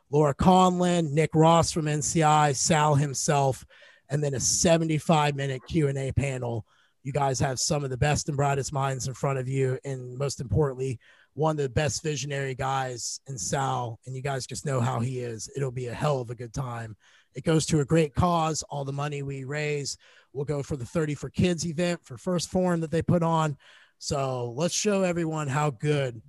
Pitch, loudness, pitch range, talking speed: 140 Hz, -26 LUFS, 130-155 Hz, 200 wpm